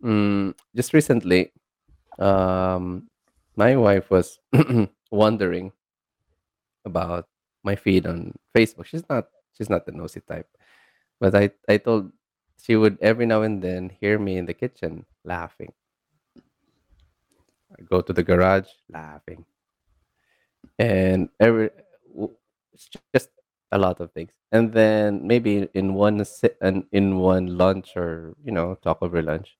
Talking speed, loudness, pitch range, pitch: 130 wpm, -22 LUFS, 90-110 Hz, 95 Hz